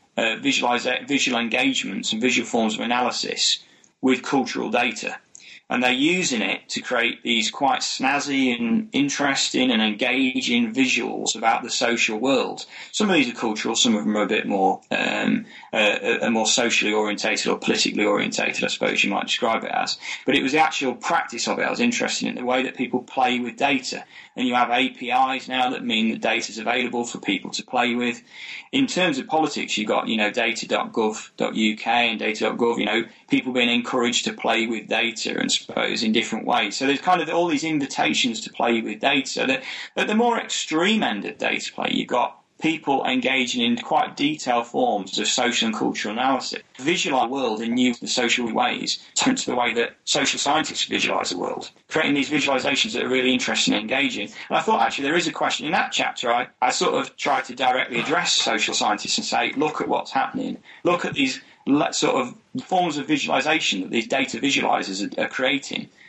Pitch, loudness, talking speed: 135 Hz, -22 LUFS, 200 wpm